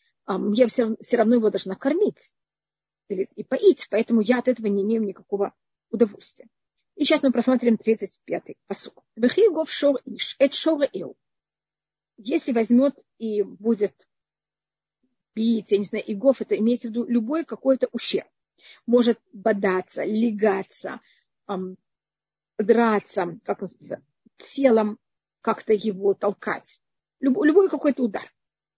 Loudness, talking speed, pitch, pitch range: -23 LUFS, 115 wpm, 230 Hz, 210-255 Hz